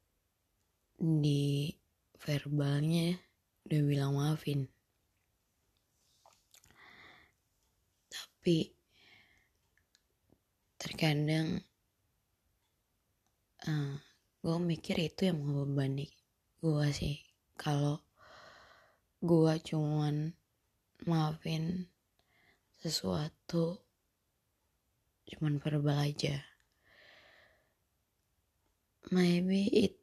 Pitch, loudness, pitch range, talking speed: 145 Hz, -34 LUFS, 105-165 Hz, 50 wpm